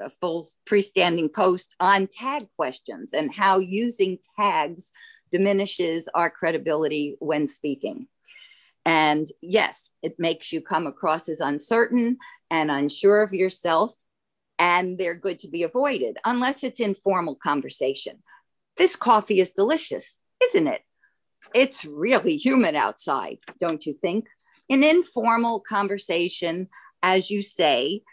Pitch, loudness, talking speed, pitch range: 200 Hz, -23 LUFS, 125 wpm, 170-255 Hz